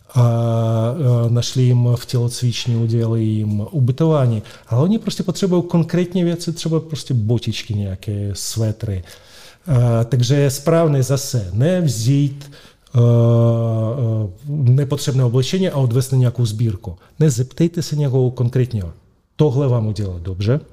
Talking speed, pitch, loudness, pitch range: 115 wpm, 125 Hz, -18 LUFS, 115-145 Hz